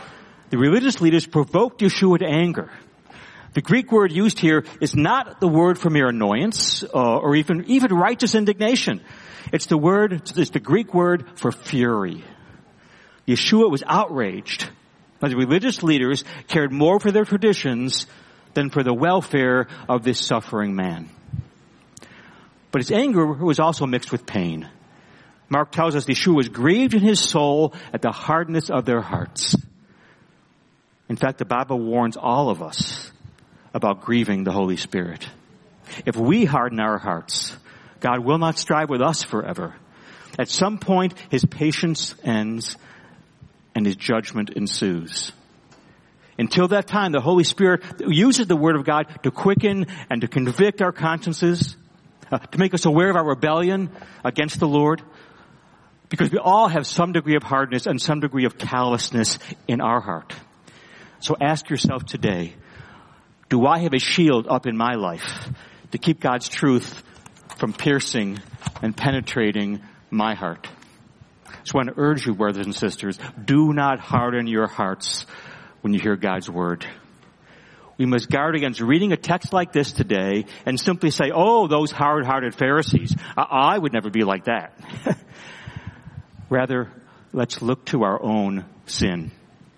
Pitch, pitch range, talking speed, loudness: 145 Hz, 120-170 Hz, 155 wpm, -21 LUFS